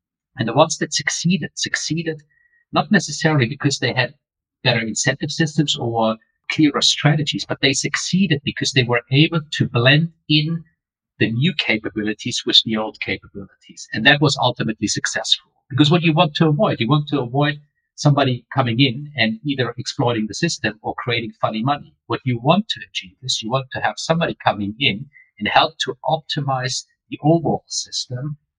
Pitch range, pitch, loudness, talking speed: 120-160 Hz, 145 Hz, -19 LUFS, 170 wpm